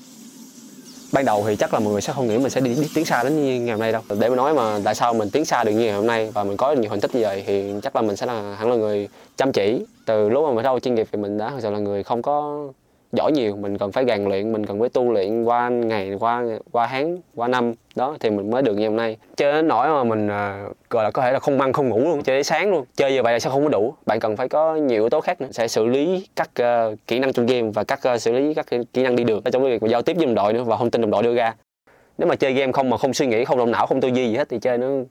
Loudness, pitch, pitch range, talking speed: -21 LUFS, 120 Hz, 105-135 Hz, 325 wpm